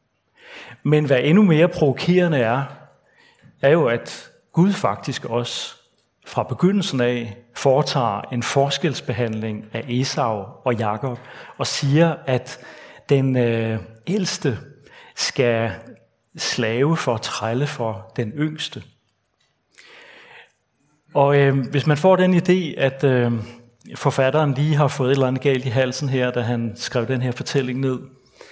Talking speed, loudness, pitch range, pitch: 135 wpm, -20 LUFS, 120-150 Hz, 135 Hz